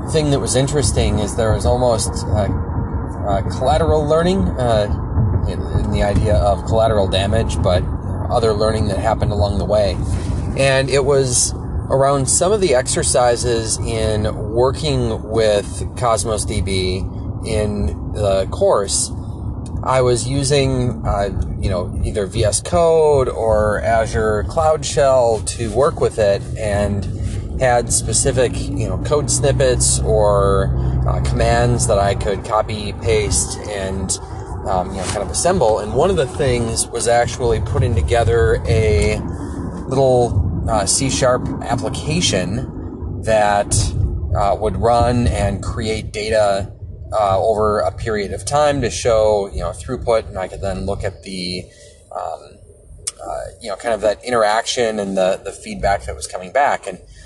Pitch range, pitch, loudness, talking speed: 95-115 Hz, 105 Hz, -17 LUFS, 145 wpm